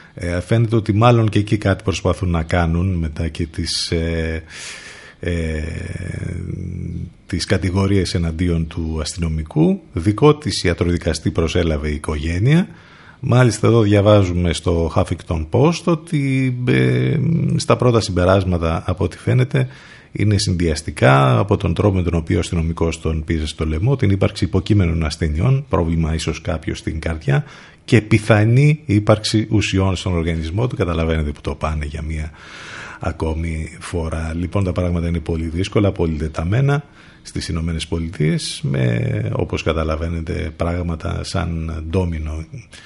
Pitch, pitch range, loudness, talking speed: 90 Hz, 80-105 Hz, -19 LUFS, 130 wpm